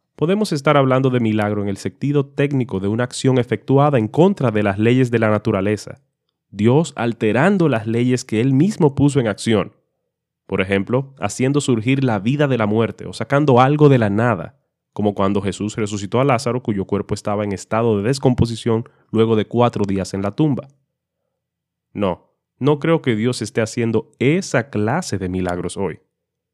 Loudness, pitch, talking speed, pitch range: -18 LUFS, 120 Hz, 175 wpm, 105-135 Hz